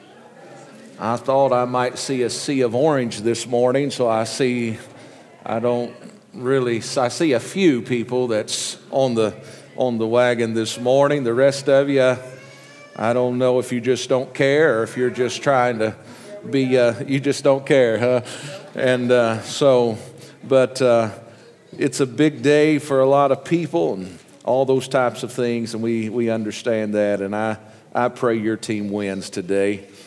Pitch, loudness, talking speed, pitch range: 125 Hz, -20 LUFS, 175 wpm, 115-135 Hz